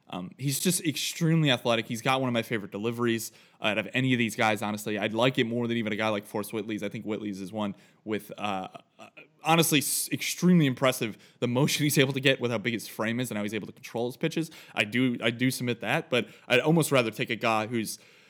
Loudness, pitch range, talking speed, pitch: -27 LUFS, 110-135 Hz, 245 wpm, 120 Hz